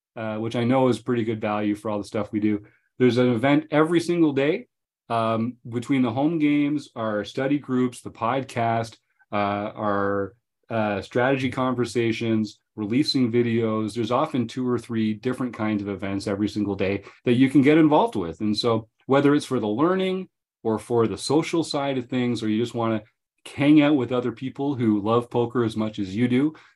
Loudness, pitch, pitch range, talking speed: -23 LUFS, 120 Hz, 110-135 Hz, 195 wpm